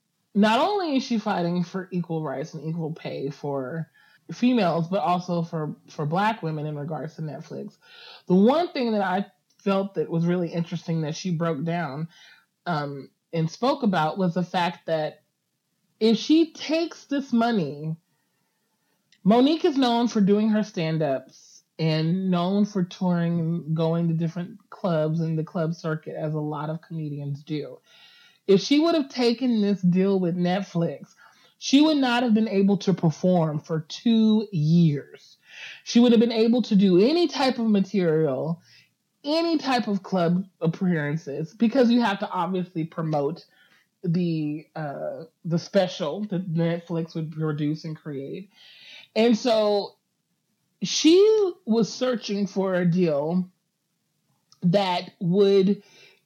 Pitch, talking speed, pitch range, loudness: 180 Hz, 150 wpm, 160-215 Hz, -24 LUFS